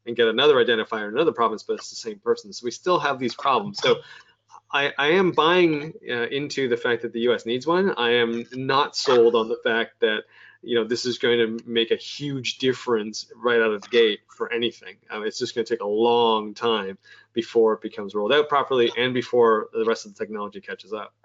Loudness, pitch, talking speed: -23 LUFS, 125 Hz, 230 wpm